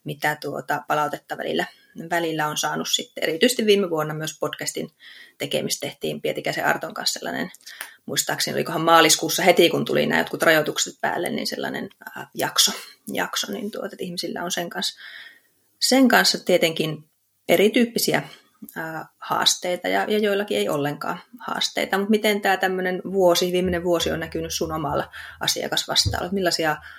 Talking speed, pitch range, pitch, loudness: 145 wpm, 160-195 Hz, 175 Hz, -22 LUFS